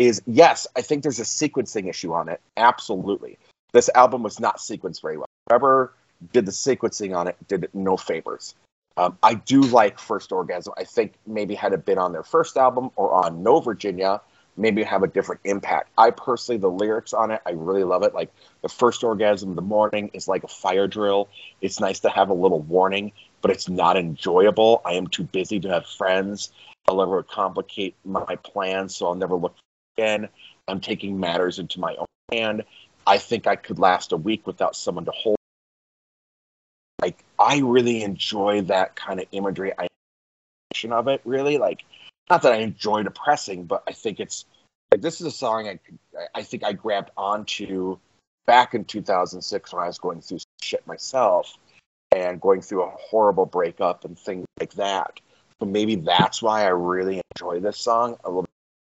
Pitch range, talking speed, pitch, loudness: 95-125 Hz, 190 wpm, 105 Hz, -22 LUFS